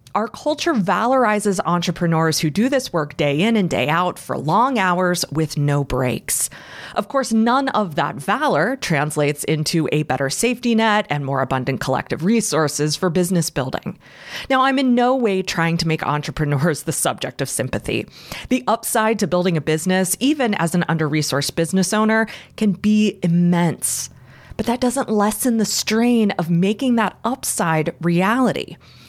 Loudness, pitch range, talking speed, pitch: -19 LUFS, 155-220 Hz, 165 wpm, 180 Hz